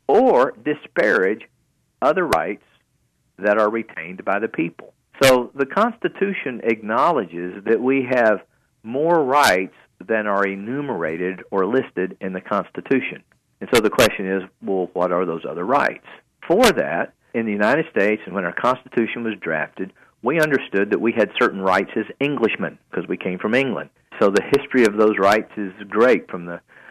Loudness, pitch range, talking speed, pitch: -20 LUFS, 95-120 Hz, 165 wpm, 105 Hz